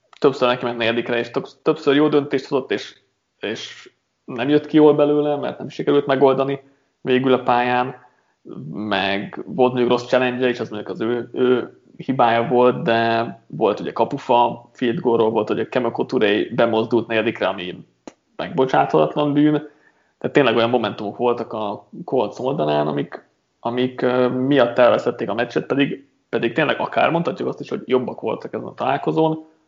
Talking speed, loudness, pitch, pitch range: 160 wpm, -20 LUFS, 125 Hz, 115-140 Hz